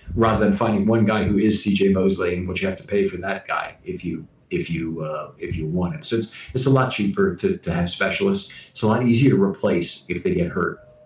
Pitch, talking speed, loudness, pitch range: 110 Hz, 255 wpm, -21 LUFS, 95-130 Hz